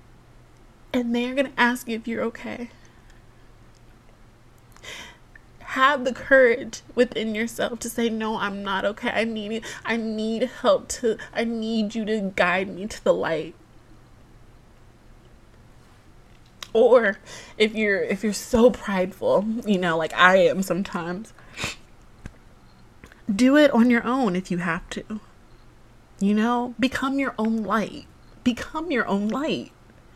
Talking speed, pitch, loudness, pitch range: 135 wpm, 220 Hz, -23 LUFS, 195-245 Hz